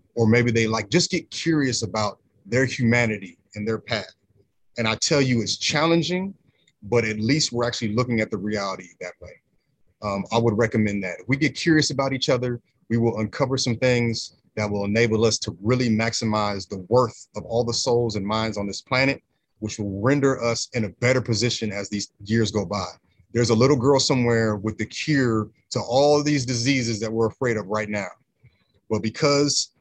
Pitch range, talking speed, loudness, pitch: 110-130 Hz, 200 wpm, -23 LUFS, 115 Hz